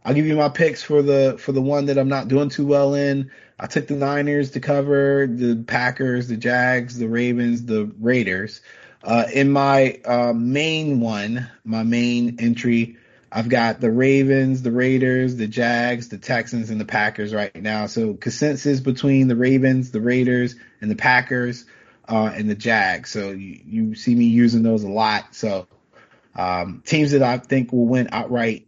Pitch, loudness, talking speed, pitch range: 125 Hz, -20 LUFS, 180 wpm, 115-140 Hz